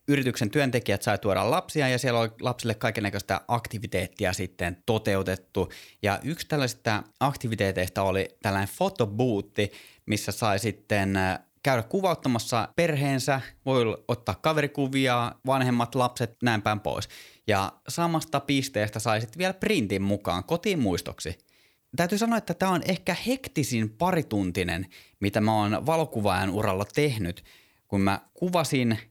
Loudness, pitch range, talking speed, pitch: -27 LUFS, 100-140 Hz, 125 wpm, 115 Hz